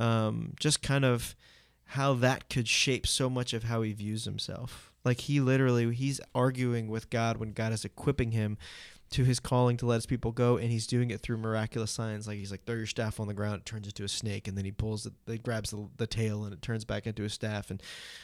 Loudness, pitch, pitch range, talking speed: -31 LUFS, 115 Hz, 105-125 Hz, 245 wpm